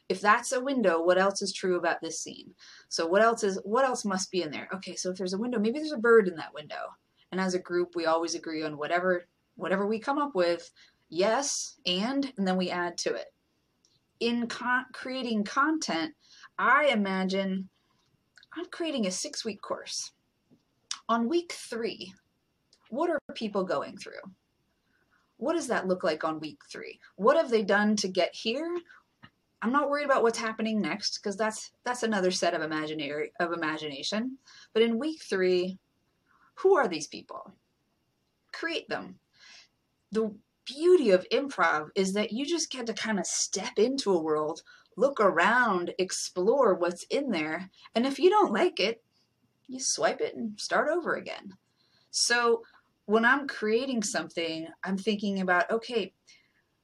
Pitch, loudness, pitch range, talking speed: 215 Hz, -28 LUFS, 180-260 Hz, 170 wpm